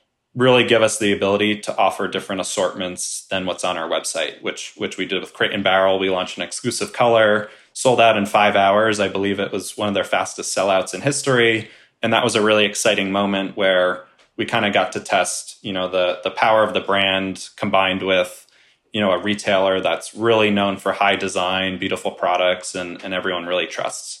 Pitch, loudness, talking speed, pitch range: 100 Hz, -19 LUFS, 210 wpm, 95-105 Hz